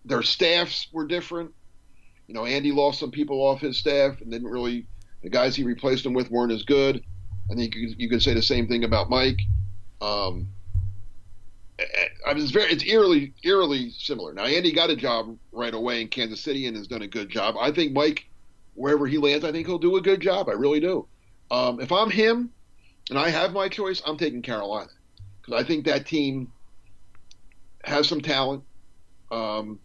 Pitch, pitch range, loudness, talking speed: 125 Hz, 105-150 Hz, -24 LUFS, 195 wpm